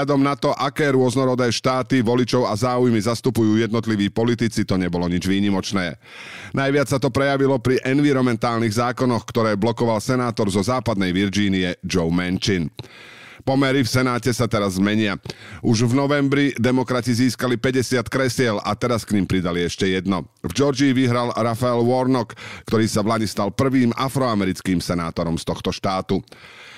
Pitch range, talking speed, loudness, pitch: 100-130 Hz, 150 wpm, -20 LUFS, 120 Hz